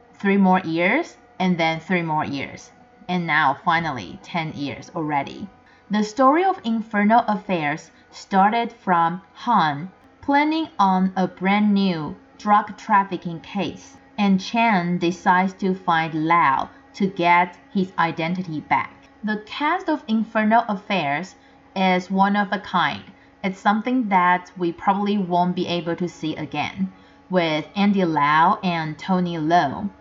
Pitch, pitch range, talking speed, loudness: 185 Hz, 170-210 Hz, 135 wpm, -21 LUFS